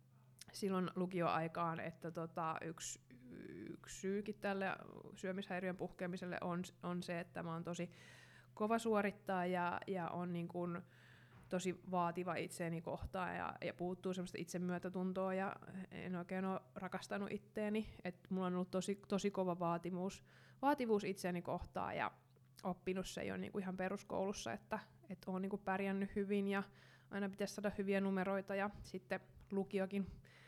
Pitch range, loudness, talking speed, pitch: 175-195 Hz, -43 LUFS, 140 wpm, 185 Hz